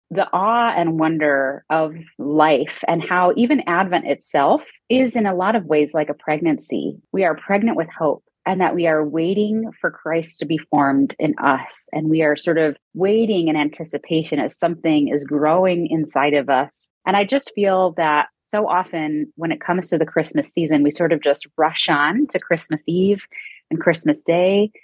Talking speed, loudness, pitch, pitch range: 190 wpm, -19 LUFS, 165 Hz, 155-190 Hz